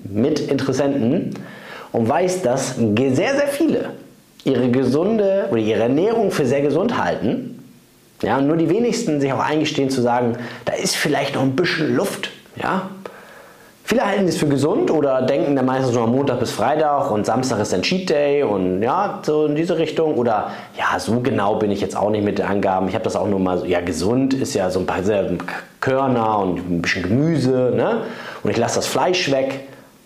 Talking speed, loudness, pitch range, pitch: 195 wpm, -19 LUFS, 110-150 Hz, 135 Hz